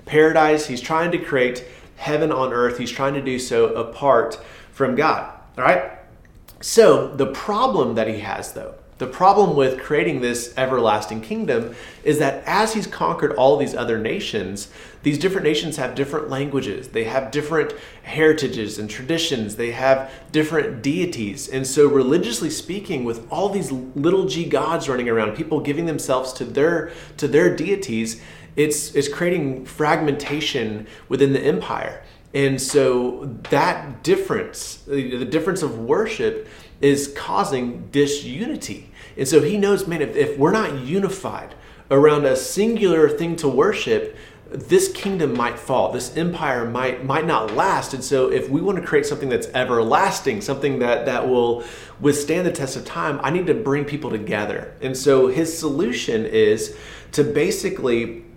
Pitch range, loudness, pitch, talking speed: 130-165 Hz, -20 LUFS, 145 Hz, 155 wpm